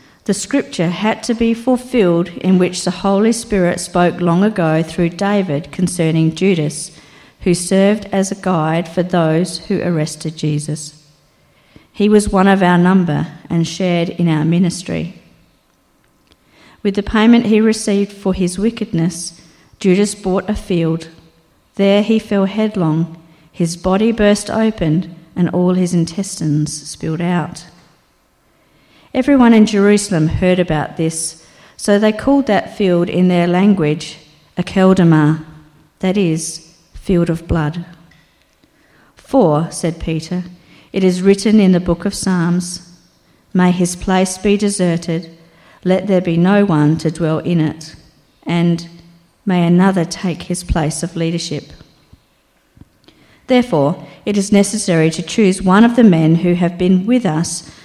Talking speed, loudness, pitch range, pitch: 140 wpm, -15 LUFS, 165-200 Hz, 175 Hz